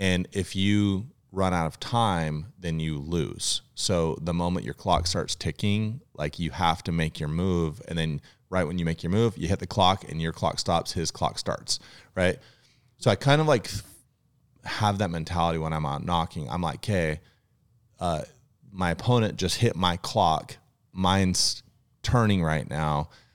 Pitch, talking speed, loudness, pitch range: 95 Hz, 180 wpm, -27 LUFS, 85-115 Hz